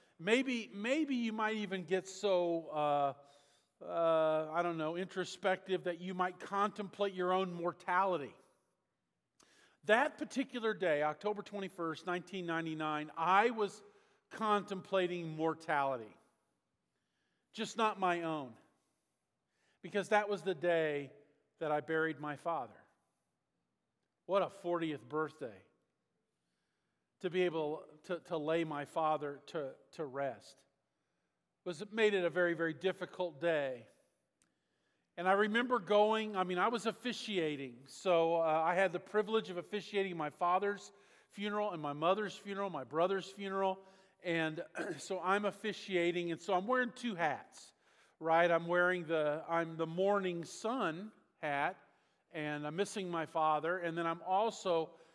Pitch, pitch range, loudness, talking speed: 180 Hz, 160-200 Hz, -36 LUFS, 135 wpm